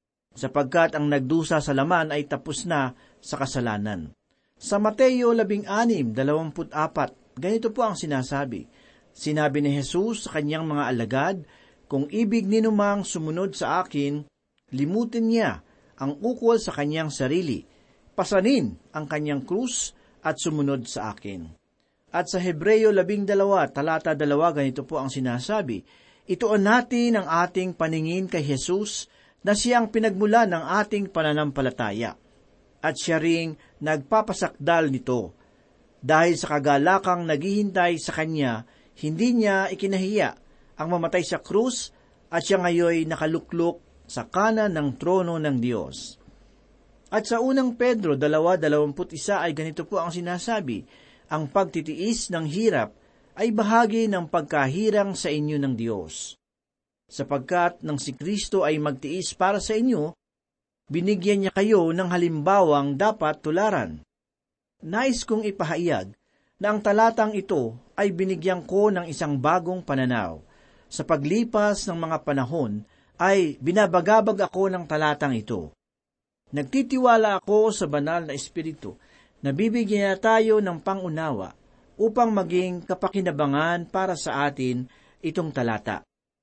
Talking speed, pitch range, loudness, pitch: 125 wpm, 145-205 Hz, -24 LUFS, 170 Hz